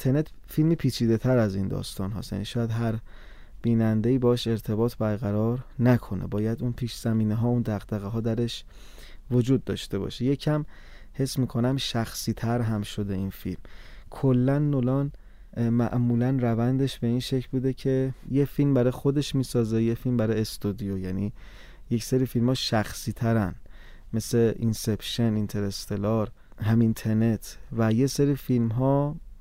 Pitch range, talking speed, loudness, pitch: 105-130 Hz, 145 wpm, -26 LUFS, 115 Hz